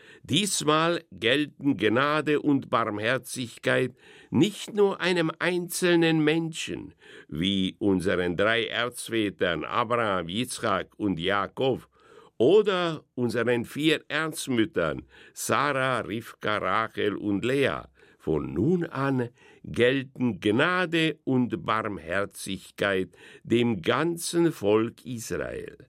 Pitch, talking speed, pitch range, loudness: 130 Hz, 90 wpm, 110-160 Hz, -26 LUFS